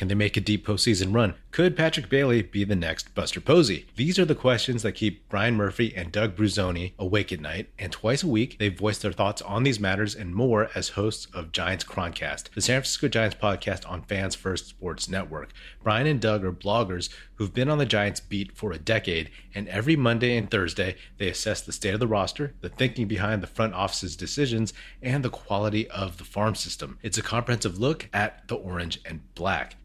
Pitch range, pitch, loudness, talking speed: 95-115 Hz, 105 Hz, -26 LUFS, 215 wpm